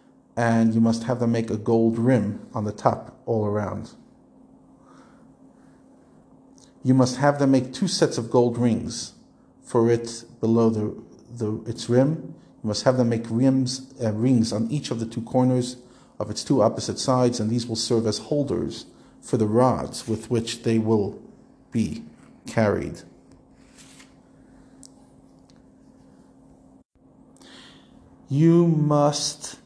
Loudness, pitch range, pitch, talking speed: -23 LUFS, 115-130 Hz, 120 Hz, 135 wpm